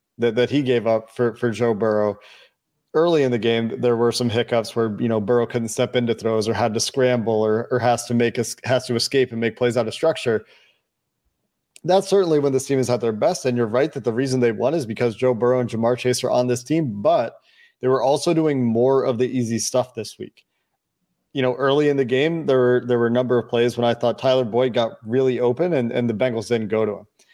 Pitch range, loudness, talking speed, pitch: 115-130 Hz, -20 LUFS, 250 wpm, 120 Hz